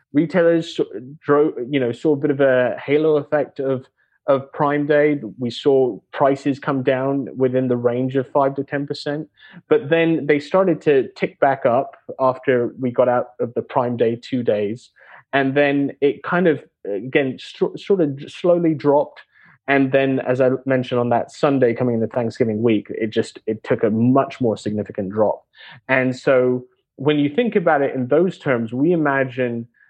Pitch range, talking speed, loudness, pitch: 125-150 Hz, 180 wpm, -19 LUFS, 135 Hz